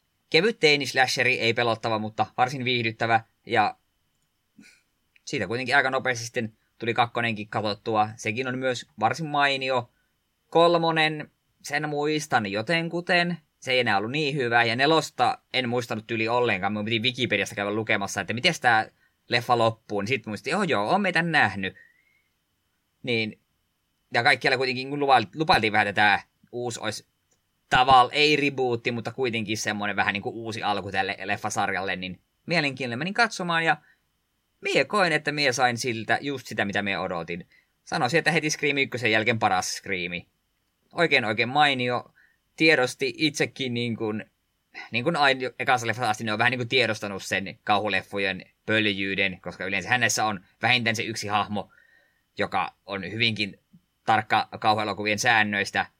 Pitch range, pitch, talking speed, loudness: 105-140 Hz, 120 Hz, 145 wpm, -24 LUFS